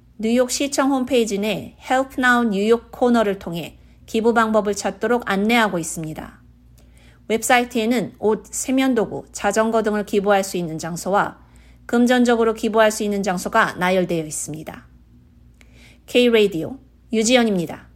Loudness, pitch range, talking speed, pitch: -19 LUFS, 175-235 Hz, 340 characters per minute, 210 Hz